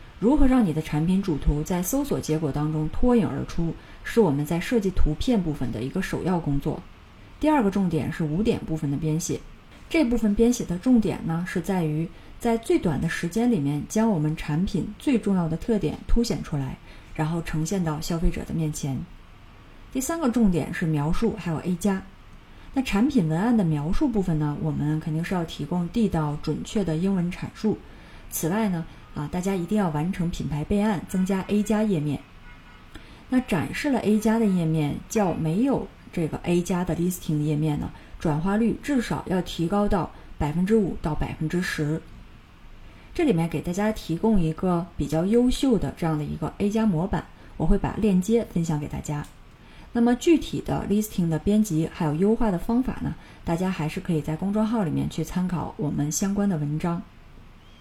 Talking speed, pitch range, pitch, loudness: 295 characters per minute, 155-215 Hz, 175 Hz, -25 LUFS